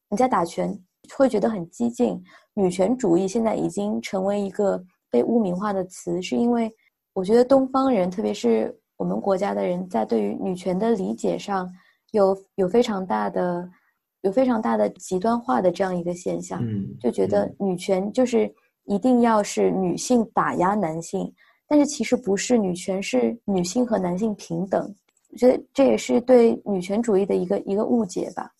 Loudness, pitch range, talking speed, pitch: -23 LUFS, 185-235 Hz, 270 characters per minute, 200 Hz